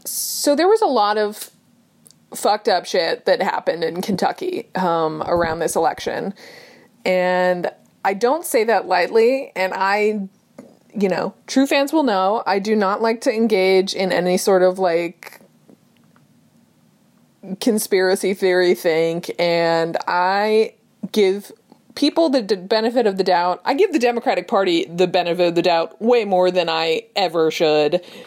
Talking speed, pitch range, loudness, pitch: 150 wpm, 180-235 Hz, -18 LUFS, 195 Hz